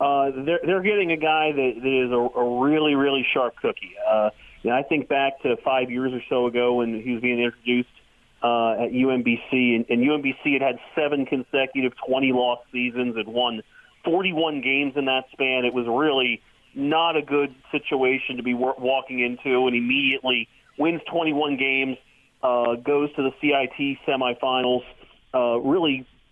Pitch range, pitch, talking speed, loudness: 125-140 Hz, 130 Hz, 175 wpm, -23 LUFS